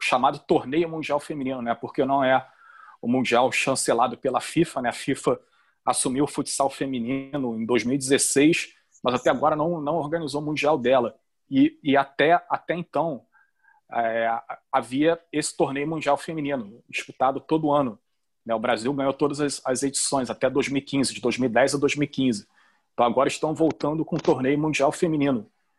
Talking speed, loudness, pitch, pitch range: 160 wpm, -24 LUFS, 140 Hz, 135-155 Hz